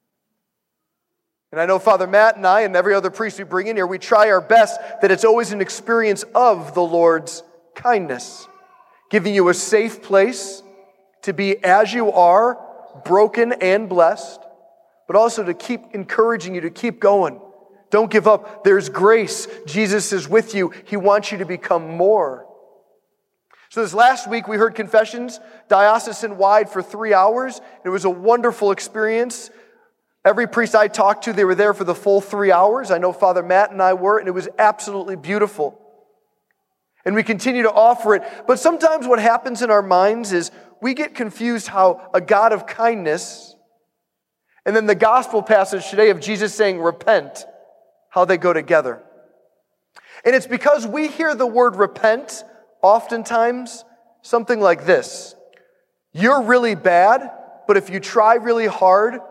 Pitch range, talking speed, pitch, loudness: 190-235 Hz, 165 wpm, 215 Hz, -17 LUFS